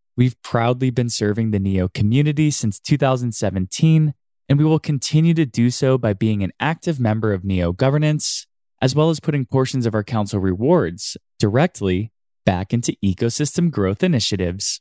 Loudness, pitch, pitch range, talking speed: -19 LUFS, 120 Hz, 105-150 Hz, 160 wpm